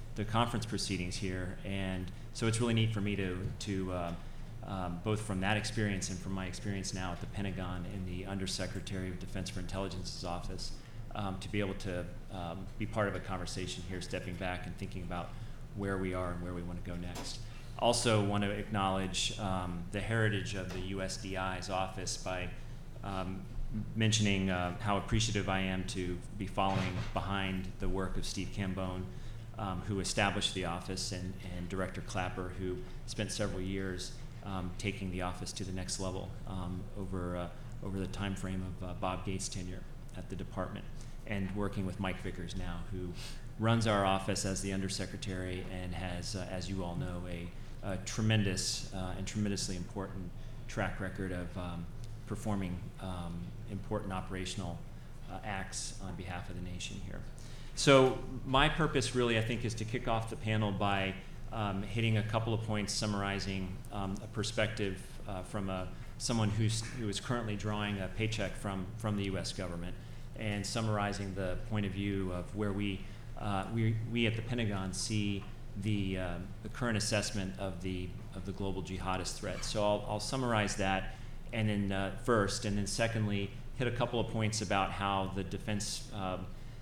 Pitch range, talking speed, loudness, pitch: 95-110 Hz, 180 wpm, -36 LUFS, 100 Hz